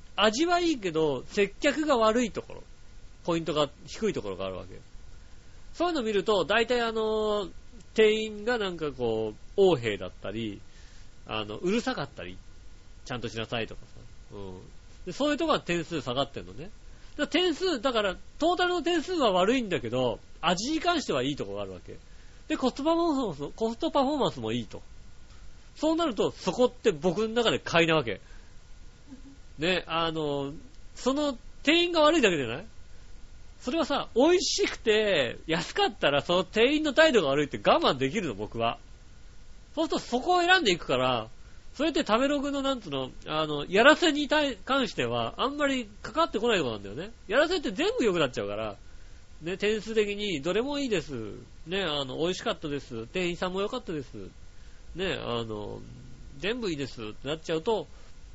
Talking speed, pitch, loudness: 360 characters per minute, 195 Hz, -28 LUFS